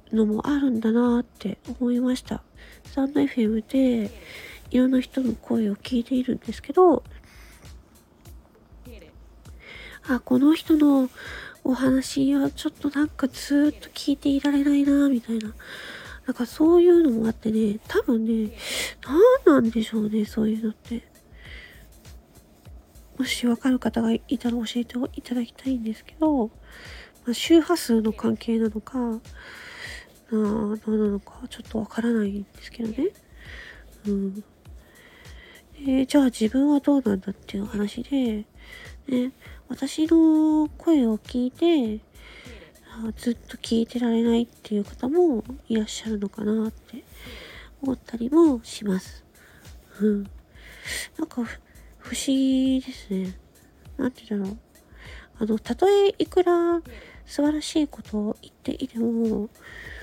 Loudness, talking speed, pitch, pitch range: -24 LUFS, 260 characters per minute, 245 Hz, 220-280 Hz